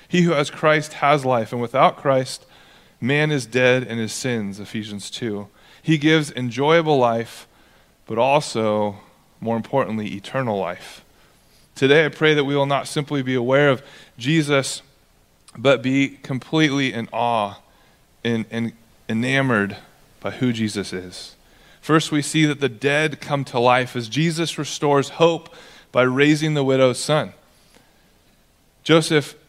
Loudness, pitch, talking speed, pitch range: -20 LUFS, 135 Hz, 140 wpm, 115-150 Hz